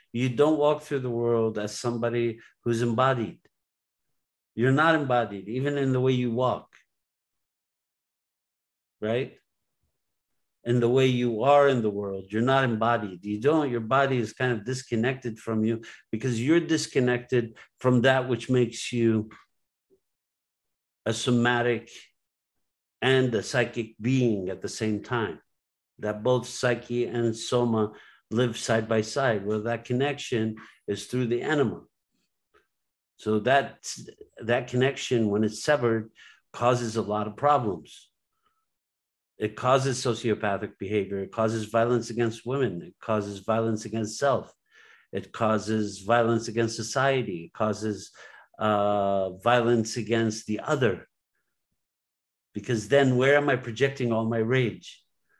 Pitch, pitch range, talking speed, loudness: 115 Hz, 110-125 Hz, 130 wpm, -26 LUFS